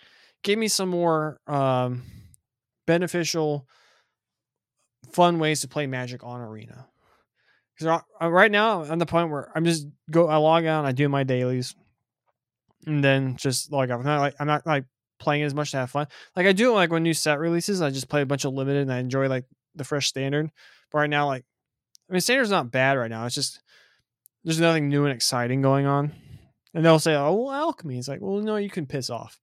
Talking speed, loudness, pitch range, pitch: 210 wpm, -24 LUFS, 135-165 Hz, 145 Hz